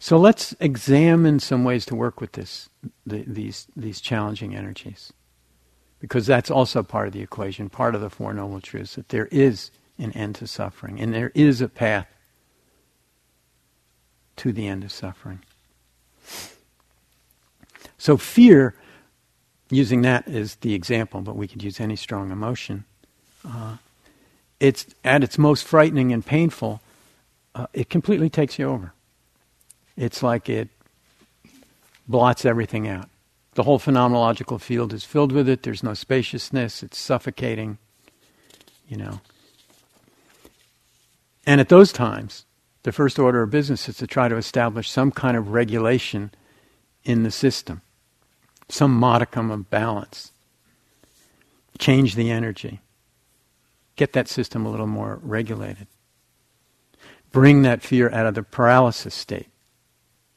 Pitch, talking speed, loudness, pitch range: 115 Hz, 135 wpm, -20 LUFS, 105-130 Hz